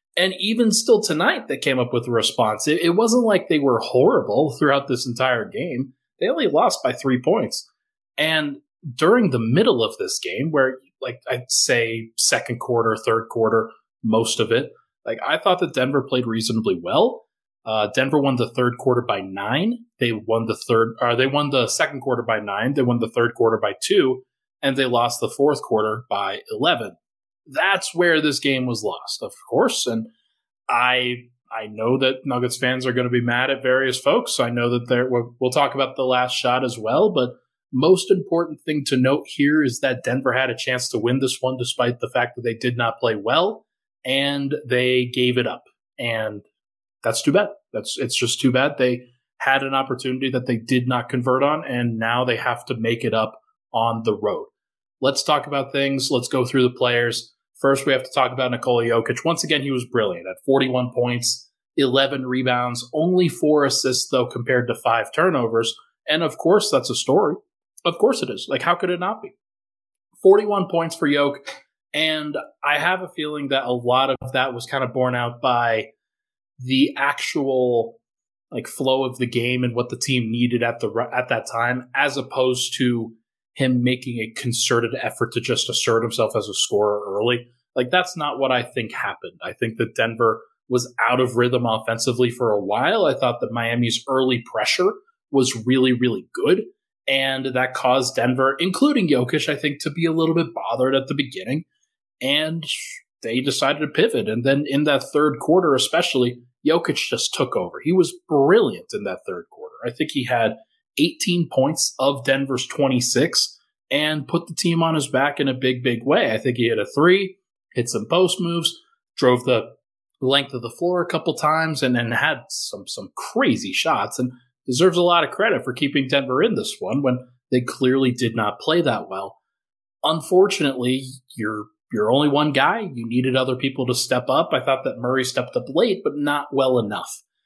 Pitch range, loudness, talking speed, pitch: 125-150 Hz, -21 LUFS, 195 wpm, 130 Hz